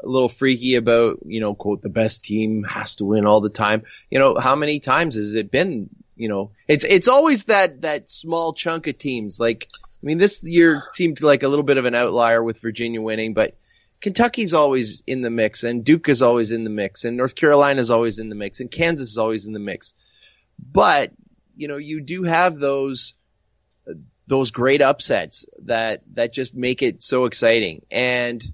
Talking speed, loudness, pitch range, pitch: 200 wpm, -19 LUFS, 110-150 Hz, 125 Hz